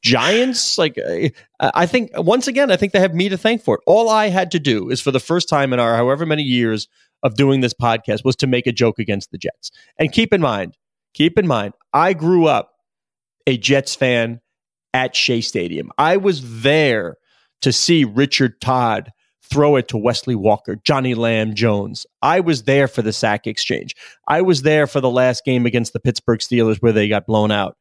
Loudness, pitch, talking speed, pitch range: -17 LUFS, 130 Hz, 205 wpm, 115-165 Hz